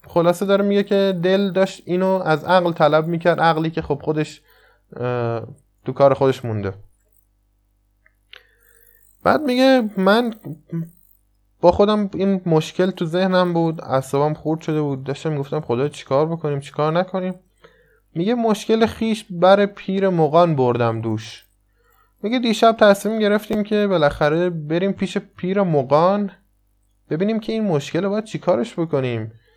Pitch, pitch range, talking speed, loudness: 165 Hz, 135-195 Hz, 135 wpm, -19 LUFS